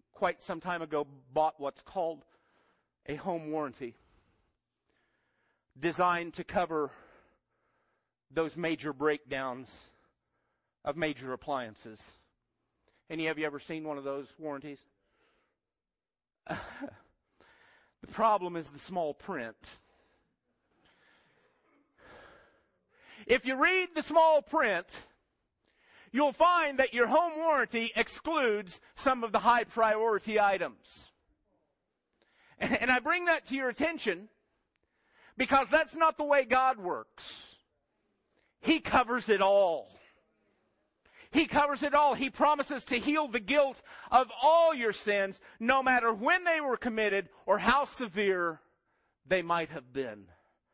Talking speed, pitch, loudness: 115 wpm, 210 Hz, -30 LUFS